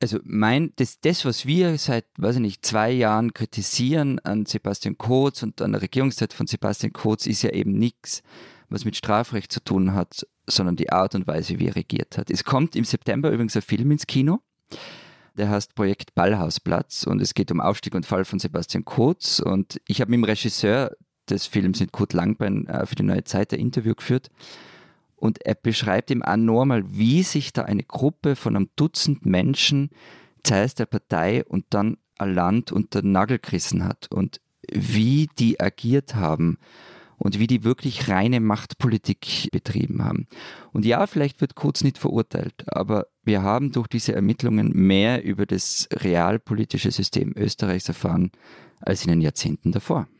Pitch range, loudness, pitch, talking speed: 100-130 Hz, -23 LUFS, 115 Hz, 175 wpm